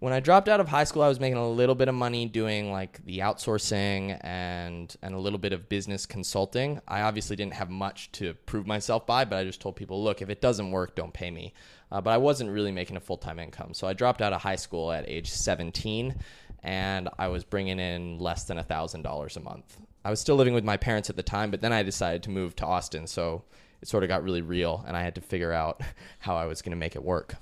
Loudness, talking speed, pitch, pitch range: -29 LUFS, 260 wpm, 95 Hz, 90-110 Hz